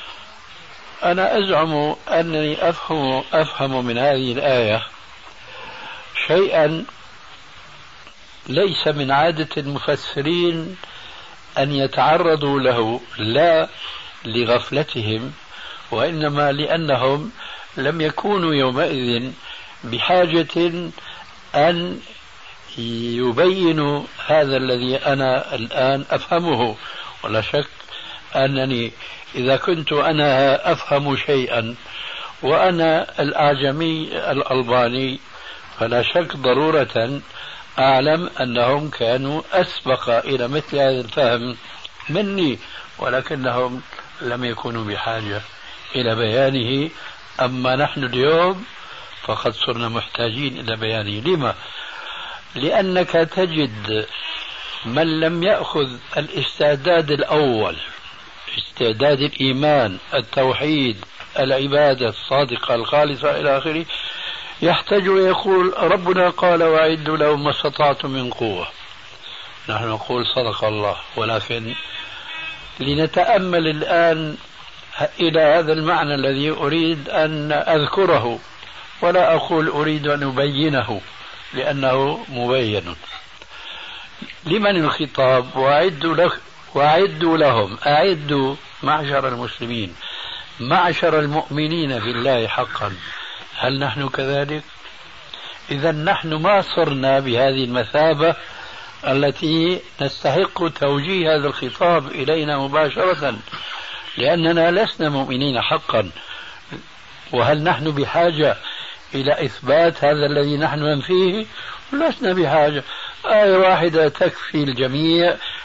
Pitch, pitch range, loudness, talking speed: 145 Hz, 130-165 Hz, -19 LUFS, 85 wpm